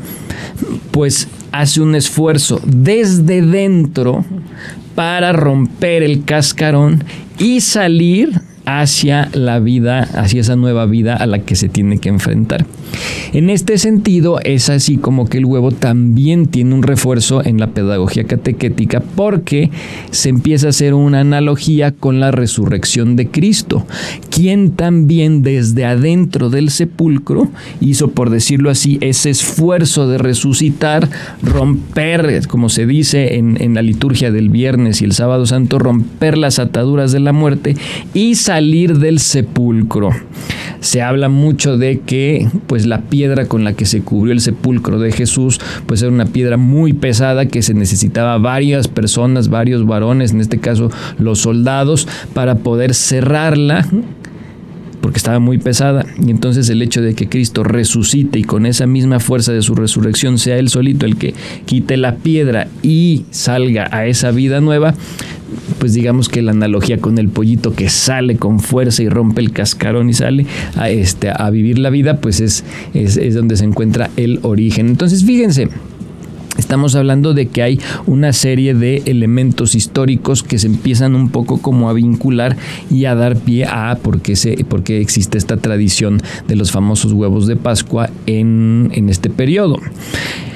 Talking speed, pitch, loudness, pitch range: 160 wpm, 130 Hz, -12 LUFS, 115-145 Hz